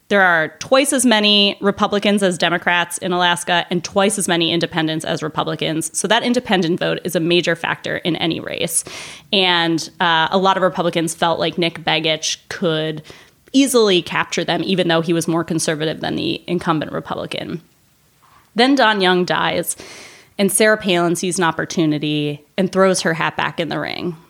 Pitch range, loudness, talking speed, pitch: 165-195 Hz, -17 LUFS, 175 wpm, 175 Hz